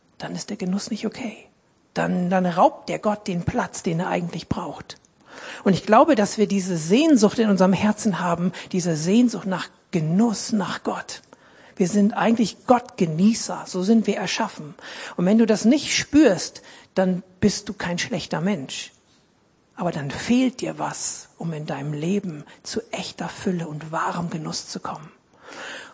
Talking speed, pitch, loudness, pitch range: 165 wpm, 195 Hz, -22 LUFS, 180-220 Hz